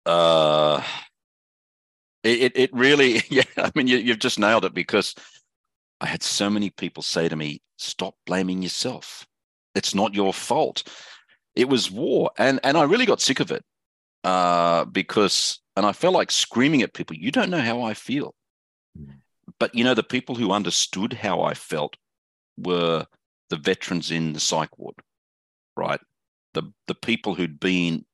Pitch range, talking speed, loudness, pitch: 80-110 Hz, 165 wpm, -22 LUFS, 90 Hz